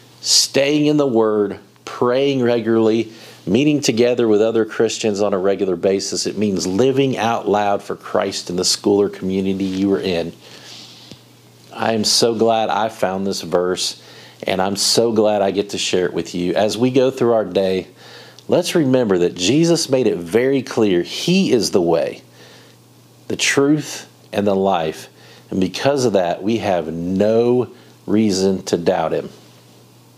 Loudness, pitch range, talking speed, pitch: -17 LUFS, 95-120 Hz, 165 wpm, 105 Hz